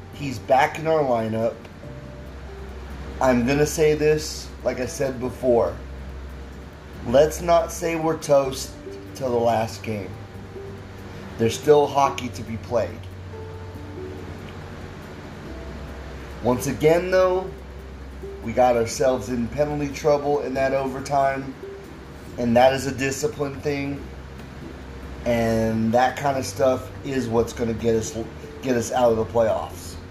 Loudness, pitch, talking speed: -22 LUFS, 115 Hz, 130 wpm